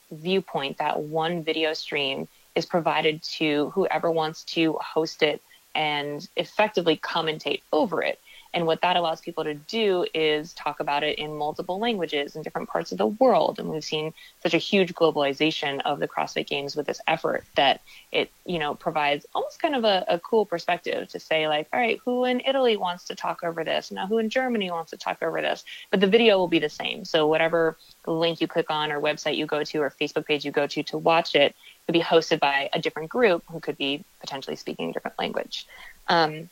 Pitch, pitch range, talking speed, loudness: 160 Hz, 150-180 Hz, 210 wpm, -25 LUFS